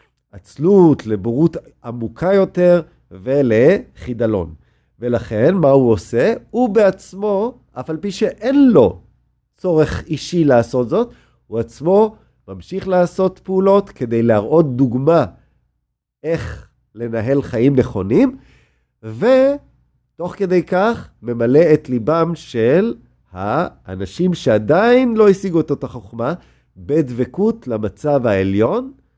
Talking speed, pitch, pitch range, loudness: 100 wpm, 140 Hz, 115-185 Hz, -16 LUFS